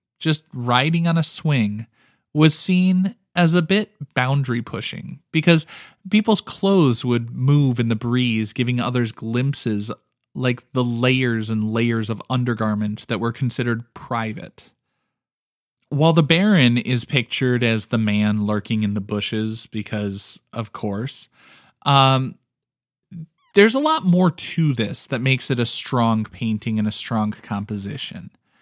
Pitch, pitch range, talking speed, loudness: 125 Hz, 110-150 Hz, 140 wpm, -20 LUFS